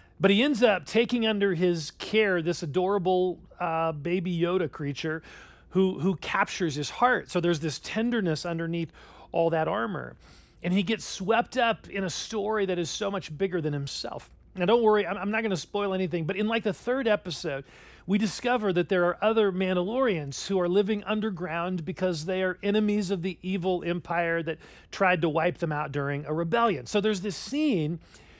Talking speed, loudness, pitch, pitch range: 190 wpm, -27 LUFS, 185 Hz, 170-210 Hz